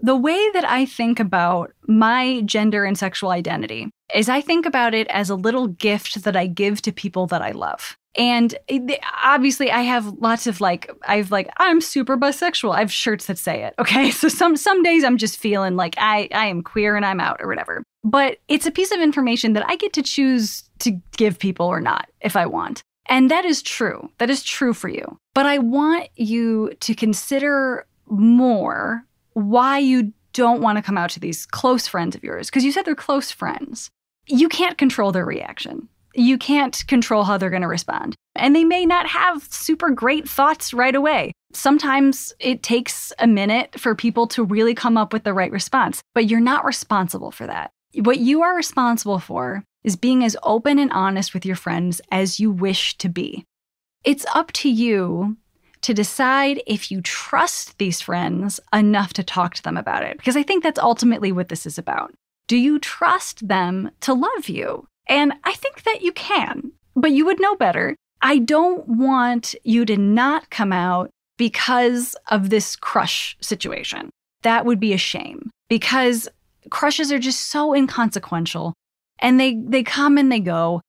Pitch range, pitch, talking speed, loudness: 205-275 Hz, 235 Hz, 190 wpm, -19 LUFS